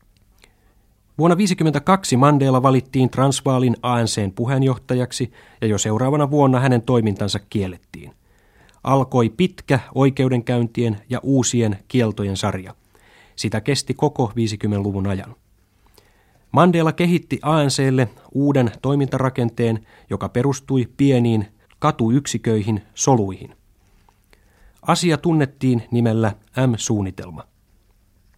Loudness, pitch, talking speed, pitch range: -19 LUFS, 120 Hz, 85 wpm, 105-135 Hz